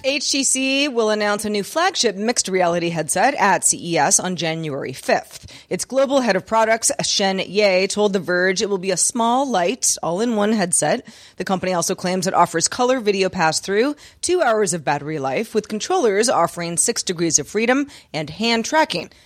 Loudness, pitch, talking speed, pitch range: -19 LUFS, 205 Hz, 175 wpm, 180-235 Hz